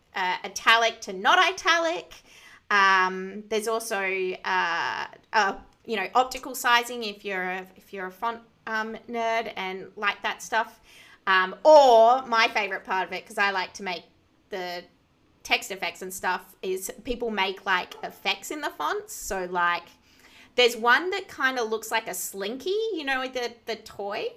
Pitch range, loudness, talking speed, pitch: 190-240 Hz, -25 LUFS, 165 wpm, 220 Hz